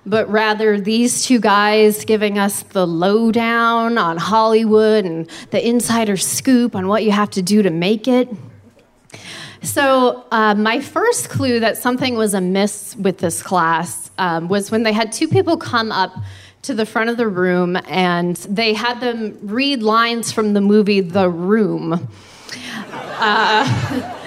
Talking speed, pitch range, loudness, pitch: 155 wpm, 190-230 Hz, -16 LUFS, 215 Hz